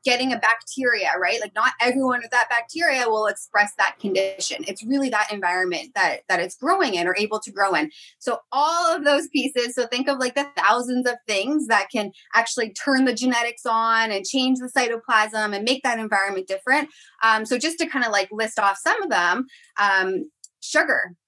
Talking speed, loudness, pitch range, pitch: 200 wpm, -21 LUFS, 205-265 Hz, 235 Hz